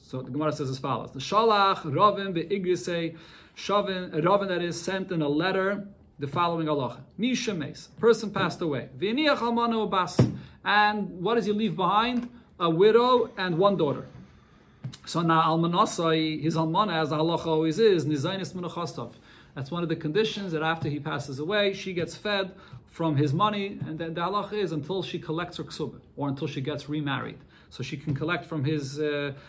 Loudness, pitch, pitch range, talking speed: -27 LUFS, 170 Hz, 150-200 Hz, 180 wpm